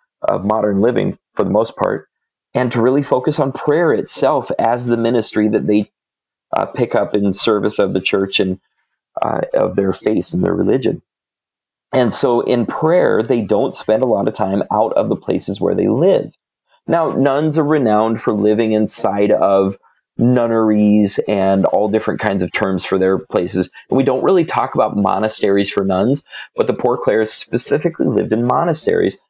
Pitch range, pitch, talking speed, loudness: 100-115 Hz, 110 Hz, 180 wpm, -16 LUFS